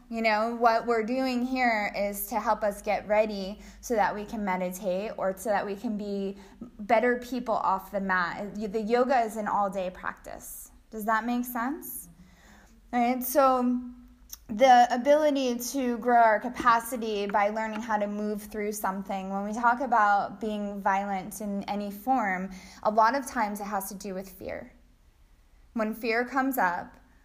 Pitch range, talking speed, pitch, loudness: 200-245 Hz, 170 wpm, 220 Hz, -27 LUFS